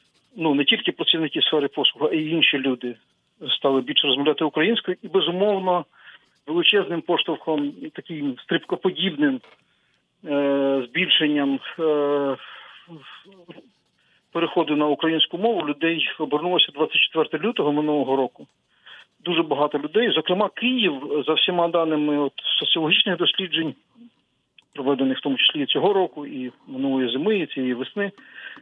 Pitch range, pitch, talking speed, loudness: 145-185 Hz, 160 Hz, 115 wpm, -21 LUFS